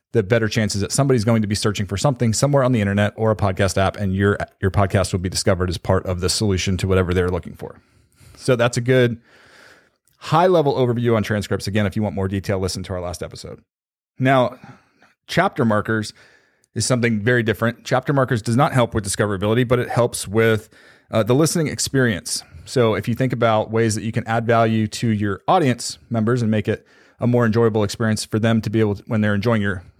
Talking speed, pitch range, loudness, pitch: 220 wpm, 100-120 Hz, -19 LUFS, 110 Hz